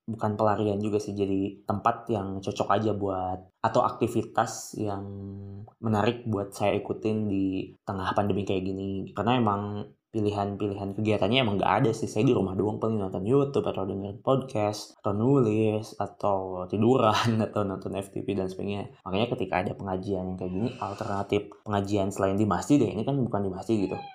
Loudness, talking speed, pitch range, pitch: -28 LUFS, 170 wpm, 95-110 Hz, 100 Hz